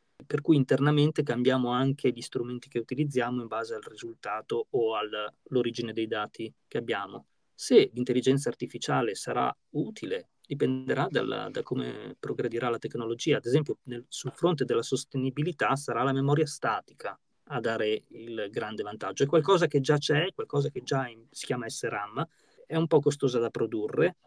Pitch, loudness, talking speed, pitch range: 135 Hz, -29 LUFS, 160 wpm, 120-155 Hz